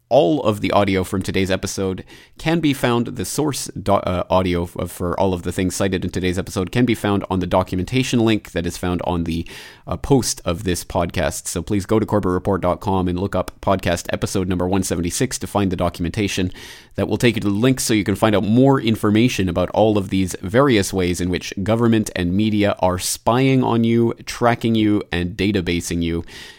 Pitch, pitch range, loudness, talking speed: 95 Hz, 90-110 Hz, -19 LUFS, 210 wpm